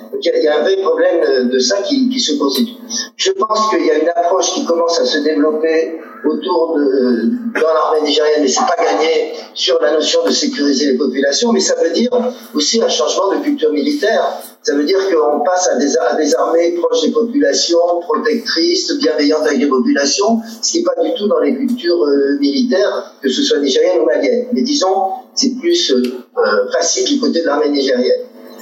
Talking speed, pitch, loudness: 205 wpm, 200 Hz, -14 LUFS